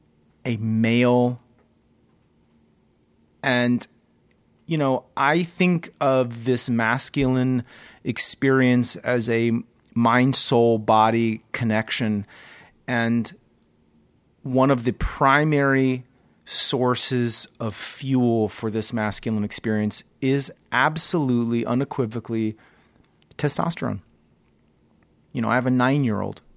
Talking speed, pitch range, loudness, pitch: 95 wpm, 110-130 Hz, -22 LUFS, 120 Hz